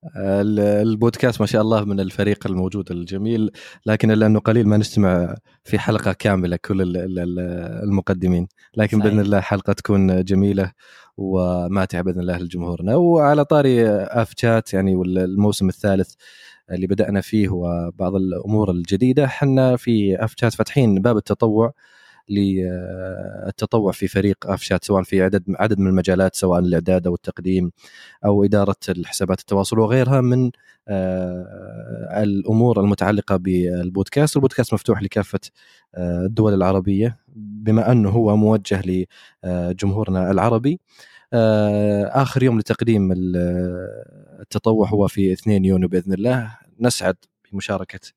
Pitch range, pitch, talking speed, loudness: 95-110 Hz, 100 Hz, 115 wpm, -19 LUFS